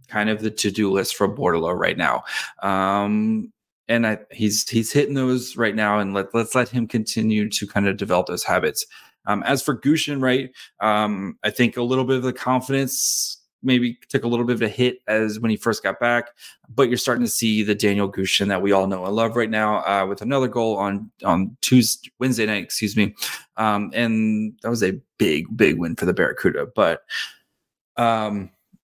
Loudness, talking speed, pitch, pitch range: -21 LUFS, 205 wpm, 110 Hz, 105-125 Hz